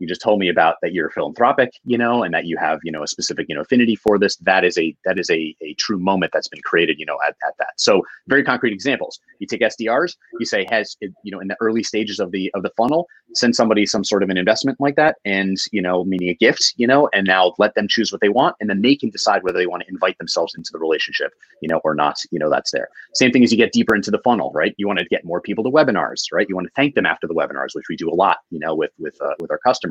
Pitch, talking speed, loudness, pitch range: 105 Hz, 295 wpm, -18 LUFS, 95-125 Hz